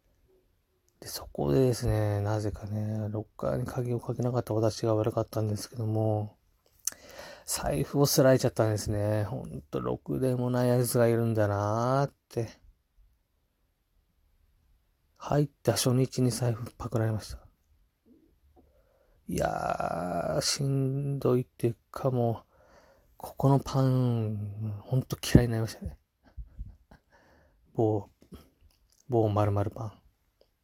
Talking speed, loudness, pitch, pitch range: 235 characters per minute, -29 LUFS, 110 Hz, 90-125 Hz